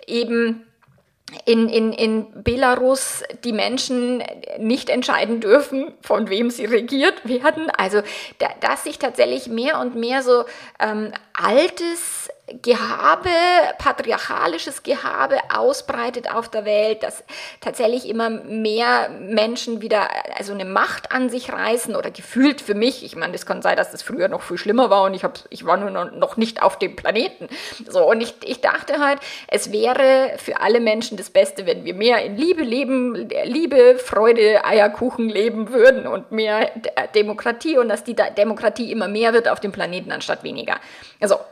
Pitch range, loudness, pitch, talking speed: 215-270 Hz, -19 LUFS, 235 Hz, 160 wpm